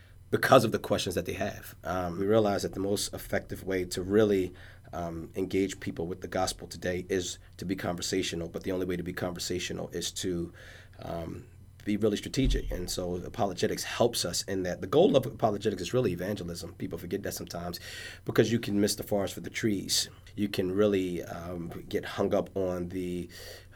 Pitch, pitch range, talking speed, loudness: 95 Hz, 90-100 Hz, 195 wpm, -31 LUFS